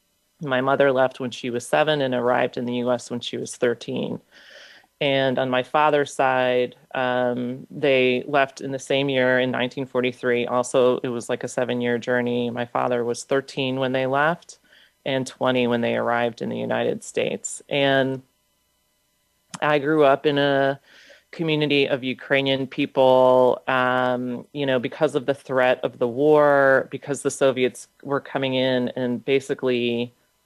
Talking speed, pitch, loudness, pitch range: 160 wpm, 130 Hz, -22 LUFS, 125-140 Hz